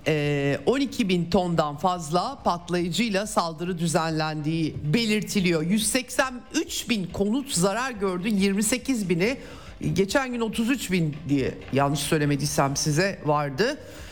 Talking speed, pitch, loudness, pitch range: 100 wpm, 185 Hz, -25 LUFS, 155-225 Hz